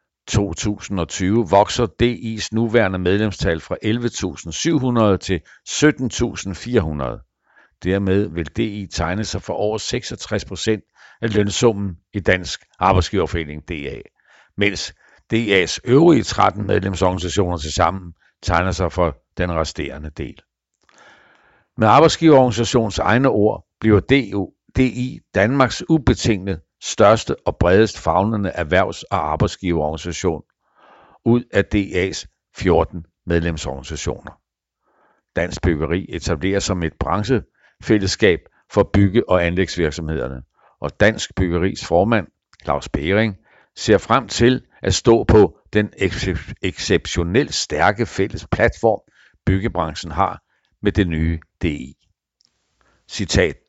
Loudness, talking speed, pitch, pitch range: -19 LUFS, 105 wpm, 95 Hz, 85-110 Hz